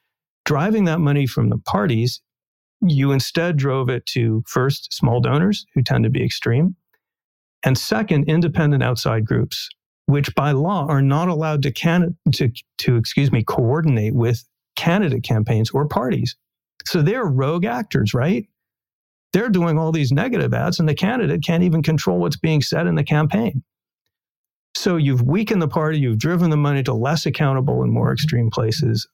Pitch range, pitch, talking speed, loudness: 125-165 Hz, 145 Hz, 165 wpm, -19 LUFS